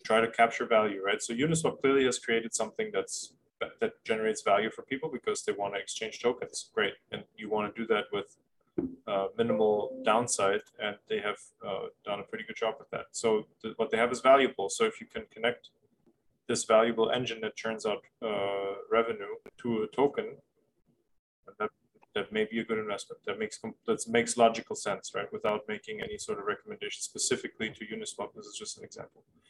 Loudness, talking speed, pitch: -31 LUFS, 195 wpm, 115 Hz